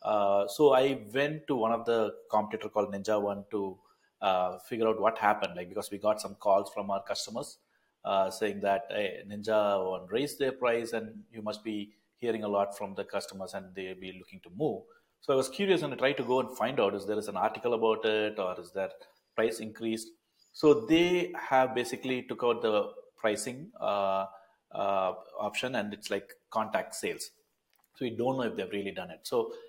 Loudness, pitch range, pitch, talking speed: -31 LUFS, 100-130 Hz, 110 Hz, 210 wpm